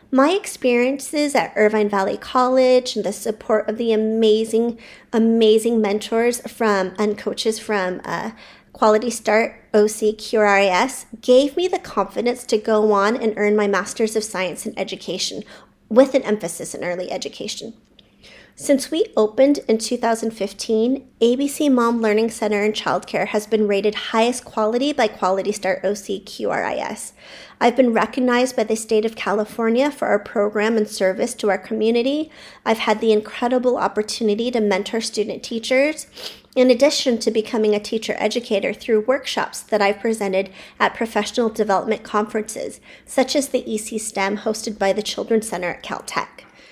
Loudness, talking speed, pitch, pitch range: -20 LUFS, 150 wpm, 220 Hz, 210-245 Hz